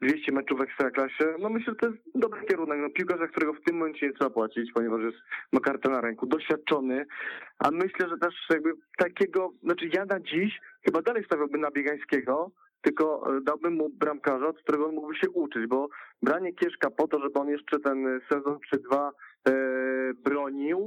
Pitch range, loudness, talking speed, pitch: 140-170 Hz, -29 LUFS, 185 wpm, 150 Hz